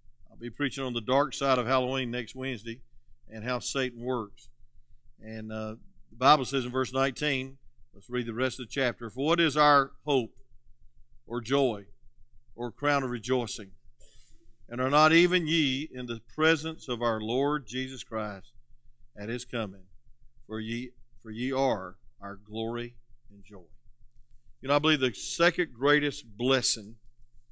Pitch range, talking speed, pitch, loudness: 115-135 Hz, 160 wpm, 125 Hz, -28 LUFS